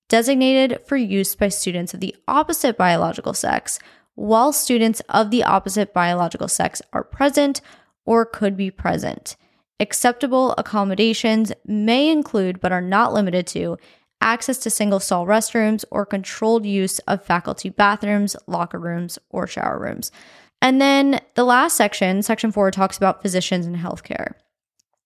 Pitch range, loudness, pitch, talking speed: 190-240 Hz, -19 LUFS, 210 Hz, 145 wpm